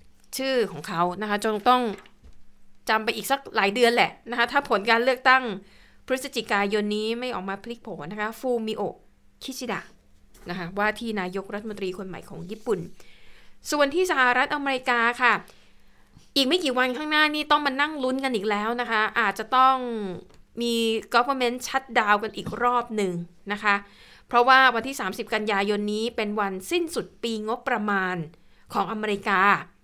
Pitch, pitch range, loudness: 225 Hz, 200-250 Hz, -24 LUFS